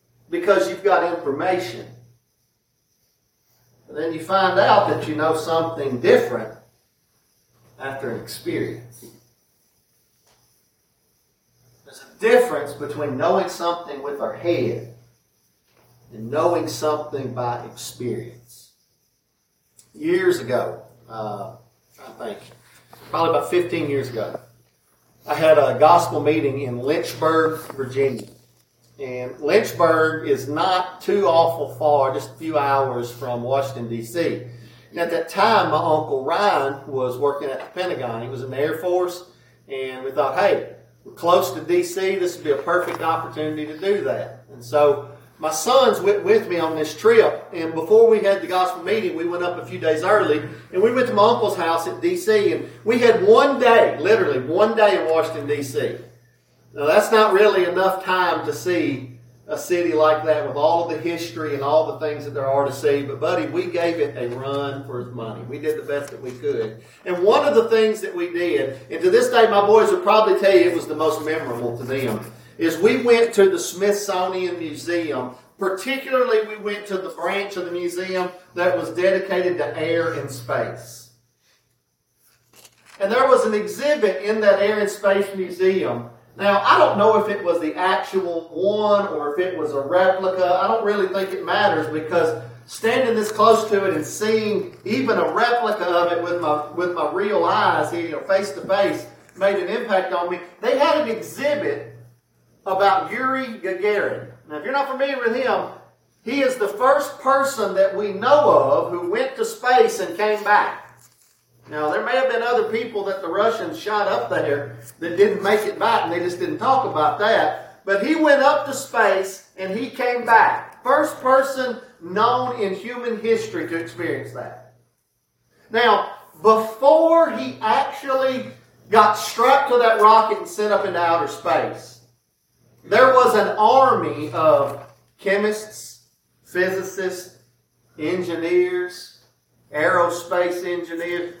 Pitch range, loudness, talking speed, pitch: 150-215 Hz, -20 LUFS, 165 wpm, 180 Hz